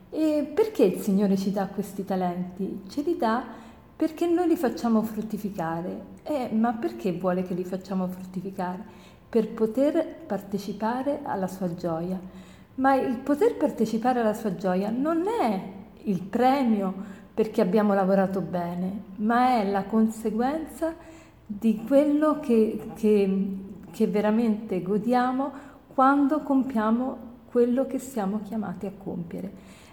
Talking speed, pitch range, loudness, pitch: 130 wpm, 195-260 Hz, -26 LUFS, 220 Hz